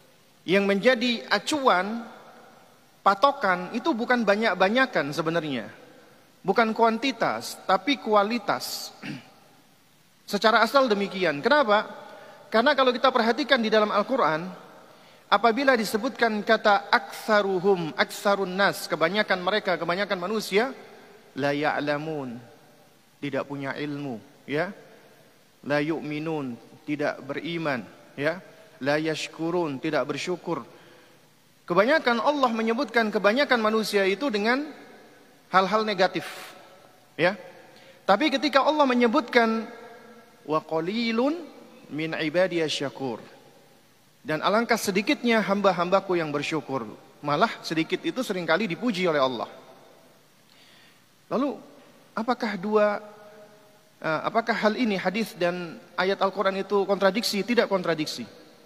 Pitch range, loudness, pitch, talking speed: 165-235 Hz, -25 LUFS, 200 Hz, 95 wpm